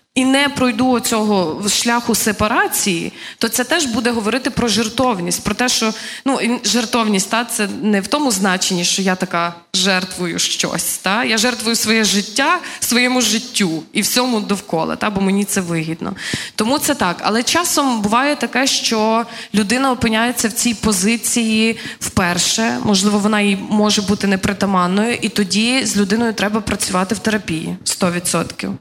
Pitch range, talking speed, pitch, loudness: 200-240 Hz, 150 wpm, 220 Hz, -16 LUFS